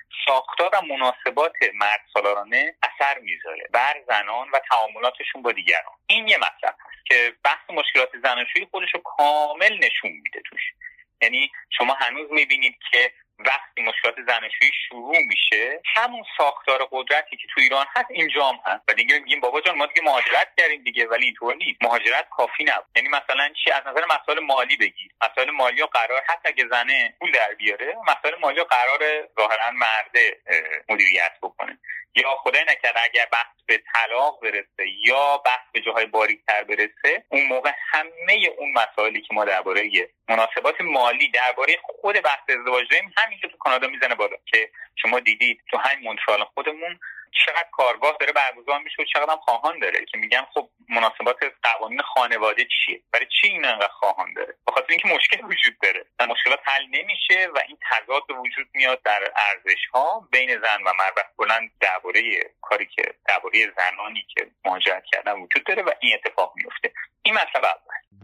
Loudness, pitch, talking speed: -20 LUFS, 170 Hz, 165 wpm